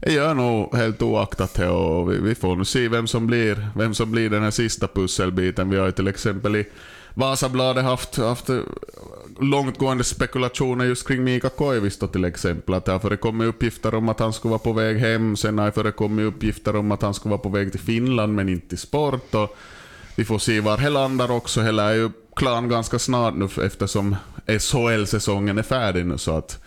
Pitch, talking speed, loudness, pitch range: 110 Hz, 200 wpm, -22 LUFS, 100-120 Hz